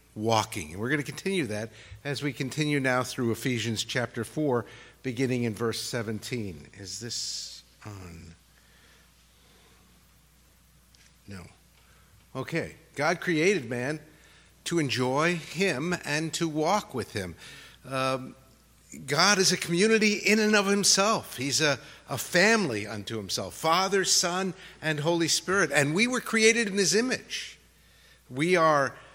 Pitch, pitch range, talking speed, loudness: 145 Hz, 115-175 Hz, 130 wpm, -26 LUFS